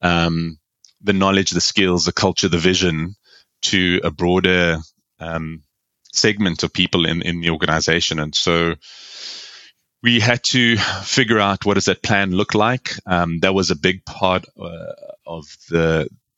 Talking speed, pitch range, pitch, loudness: 155 wpm, 85-100 Hz, 90 Hz, -17 LUFS